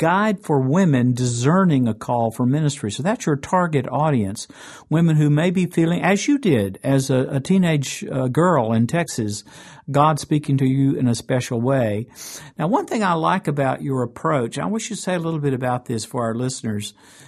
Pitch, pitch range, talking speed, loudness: 140 Hz, 125-165 Hz, 200 wpm, -20 LUFS